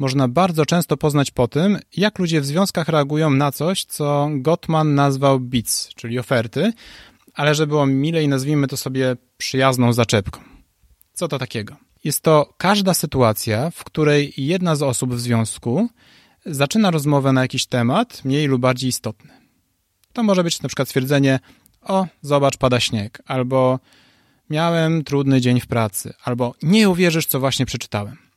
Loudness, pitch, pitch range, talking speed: -19 LUFS, 140 Hz, 125-160 Hz, 155 wpm